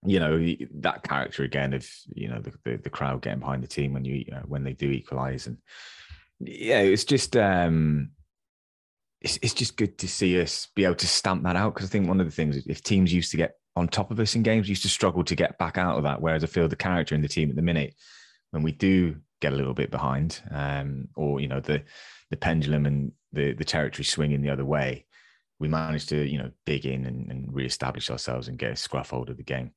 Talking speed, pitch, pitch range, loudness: 250 wpm, 75 Hz, 70-90 Hz, -27 LUFS